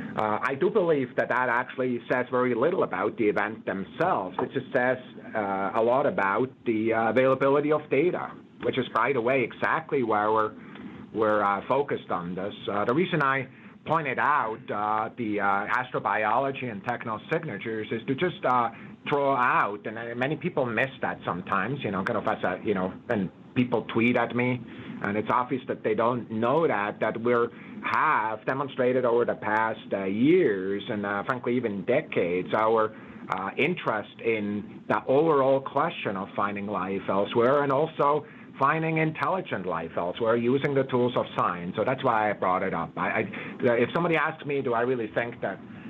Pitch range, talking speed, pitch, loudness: 110-135 Hz, 180 wpm, 120 Hz, -26 LUFS